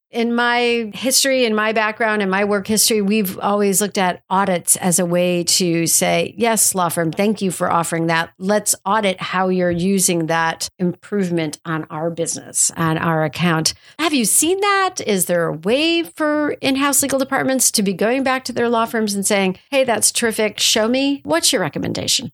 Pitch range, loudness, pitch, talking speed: 175-240 Hz, -17 LUFS, 205 Hz, 195 wpm